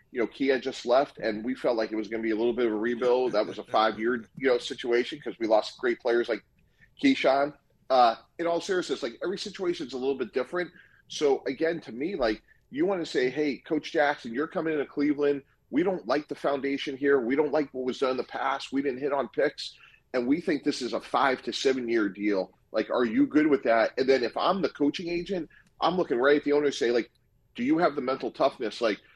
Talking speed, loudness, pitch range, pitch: 250 wpm, -27 LUFS, 125-170 Hz, 140 Hz